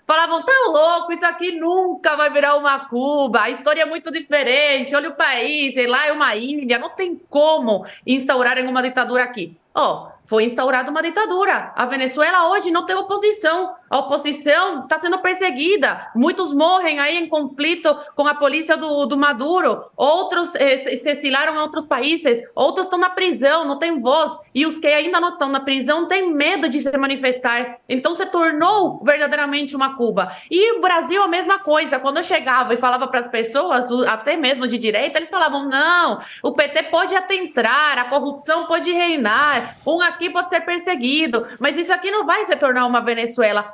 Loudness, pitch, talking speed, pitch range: -18 LUFS, 295 Hz, 185 wpm, 270-340 Hz